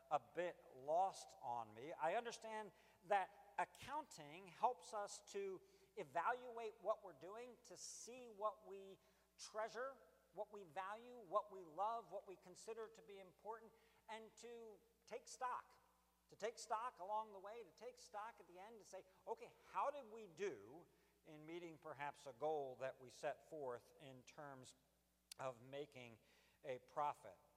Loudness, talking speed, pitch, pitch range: -50 LUFS, 155 wpm, 205 Hz, 170-225 Hz